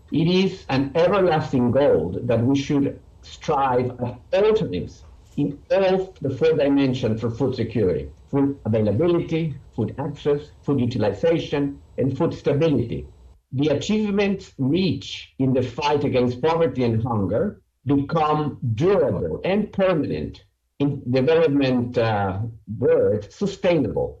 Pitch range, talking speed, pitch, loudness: 125-165 Hz, 115 wpm, 140 Hz, -22 LUFS